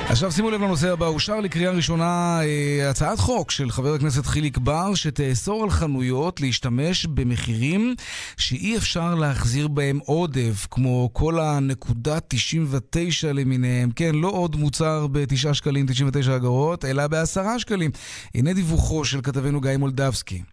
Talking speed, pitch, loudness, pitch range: 135 wpm, 145 Hz, -22 LUFS, 135-165 Hz